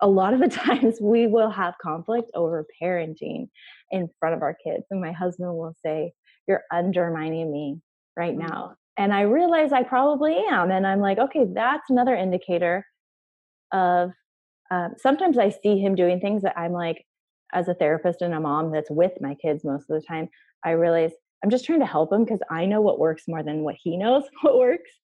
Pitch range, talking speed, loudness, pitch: 165-225 Hz, 200 wpm, -23 LUFS, 180 Hz